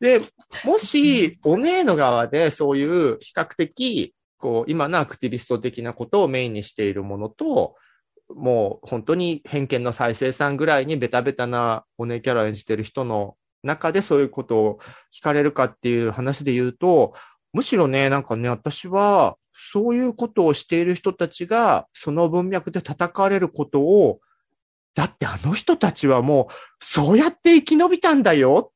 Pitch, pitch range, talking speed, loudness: 150 Hz, 125-205 Hz, 335 characters per minute, -21 LUFS